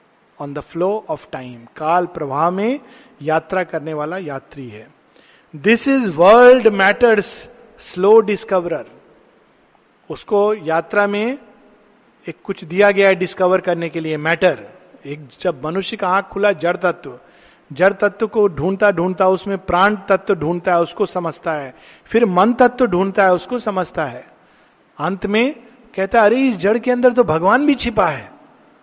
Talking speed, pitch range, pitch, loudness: 155 wpm, 170-220 Hz, 190 Hz, -16 LUFS